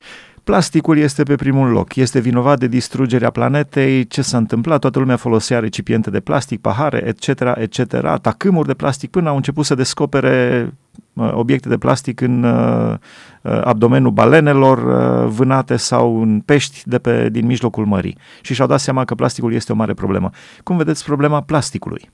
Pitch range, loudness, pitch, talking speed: 115-140 Hz, -15 LUFS, 130 Hz, 160 wpm